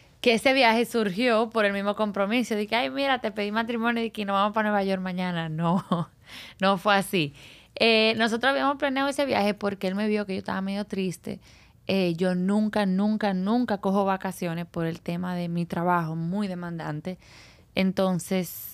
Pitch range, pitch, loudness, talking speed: 180-220 Hz, 200 Hz, -25 LUFS, 185 wpm